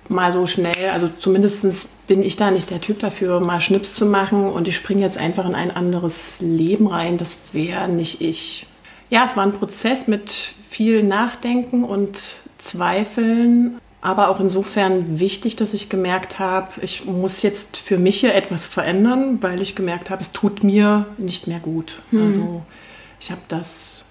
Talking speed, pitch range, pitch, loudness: 175 wpm, 180-210 Hz, 195 Hz, -19 LUFS